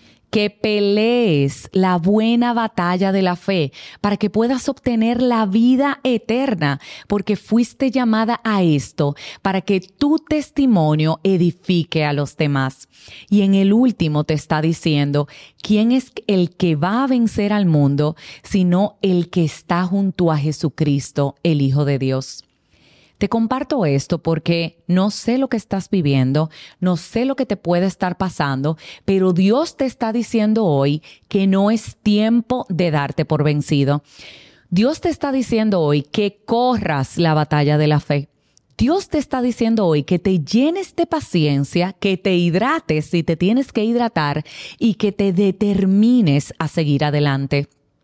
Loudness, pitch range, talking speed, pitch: -18 LUFS, 155-225 Hz, 155 wpm, 185 Hz